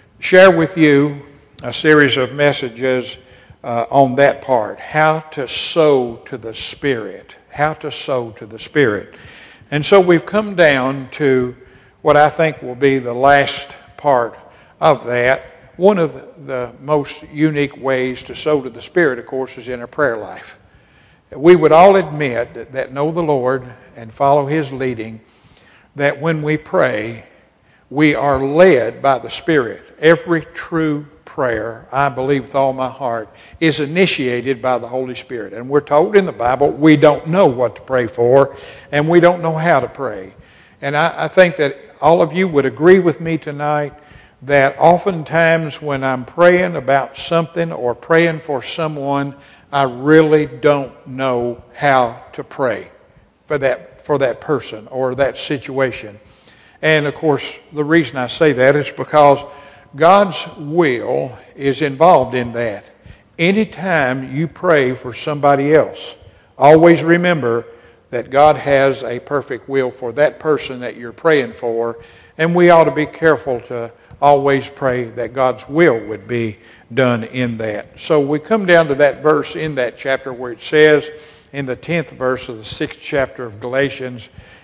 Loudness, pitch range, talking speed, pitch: -15 LUFS, 125-155 Hz, 165 wpm, 140 Hz